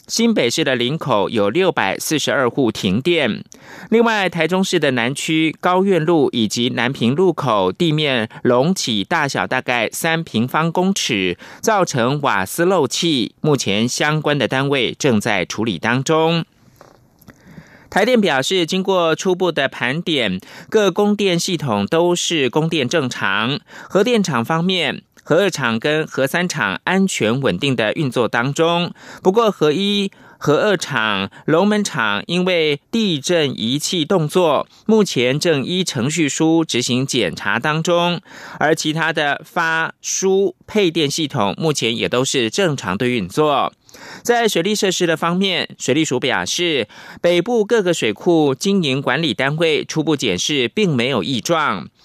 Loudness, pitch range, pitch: -17 LUFS, 135-185 Hz, 160 Hz